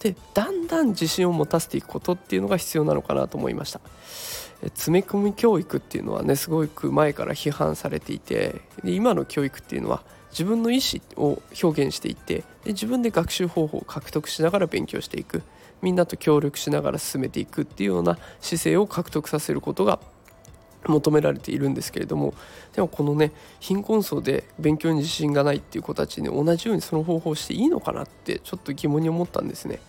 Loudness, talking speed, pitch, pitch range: -25 LUFS, 425 characters per minute, 165 Hz, 150-200 Hz